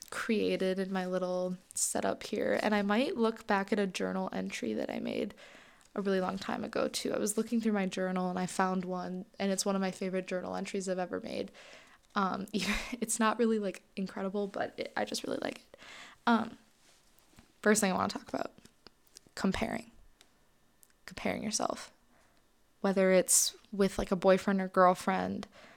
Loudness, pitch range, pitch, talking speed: -32 LUFS, 185-220 Hz, 195 Hz, 180 wpm